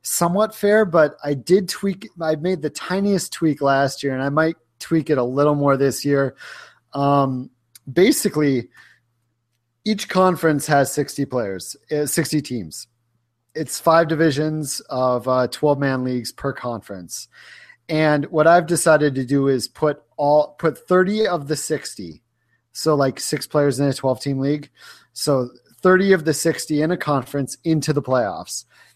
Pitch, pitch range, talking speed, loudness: 145 Hz, 130-160 Hz, 160 wpm, -20 LUFS